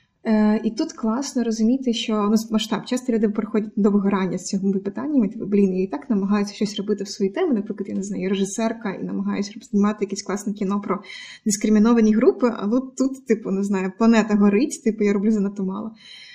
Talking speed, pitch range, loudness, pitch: 190 wpm, 200-225 Hz, -22 LUFS, 215 Hz